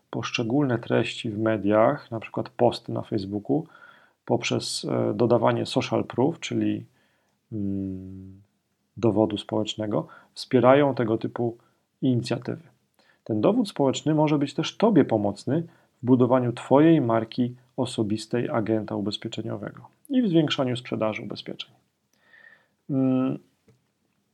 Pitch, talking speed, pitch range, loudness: 120 Hz, 100 wpm, 110-130 Hz, -25 LUFS